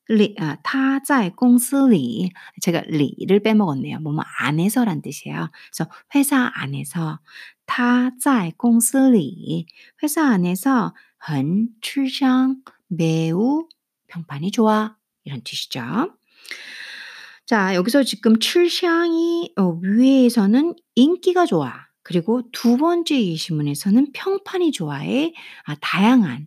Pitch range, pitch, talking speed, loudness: 180-275 Hz, 230 Hz, 220 characters per minute, -19 LUFS